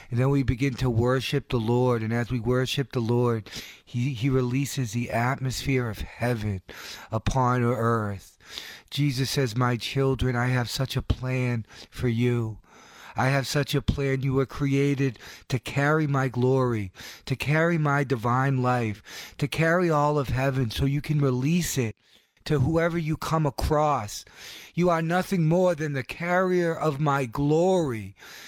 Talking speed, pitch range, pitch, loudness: 160 wpm, 120-145 Hz, 130 Hz, -26 LUFS